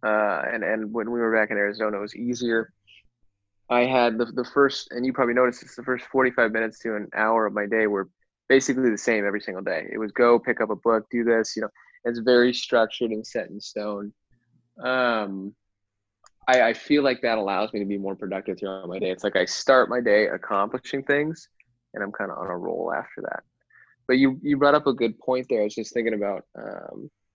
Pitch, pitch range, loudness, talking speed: 115 Hz, 105-125 Hz, -24 LUFS, 230 wpm